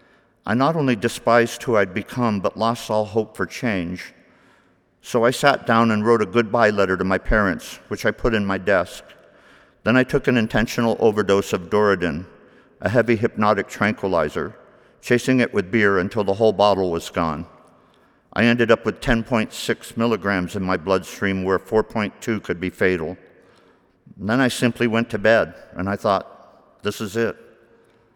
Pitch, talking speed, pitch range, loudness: 110 Hz, 170 wpm, 100-115 Hz, -20 LUFS